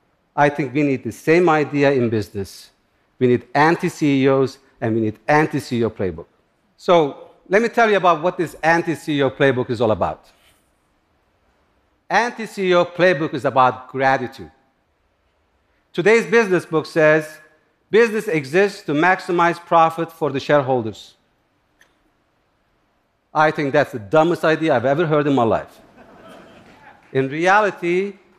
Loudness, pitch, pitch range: -18 LUFS, 150 Hz, 130-175 Hz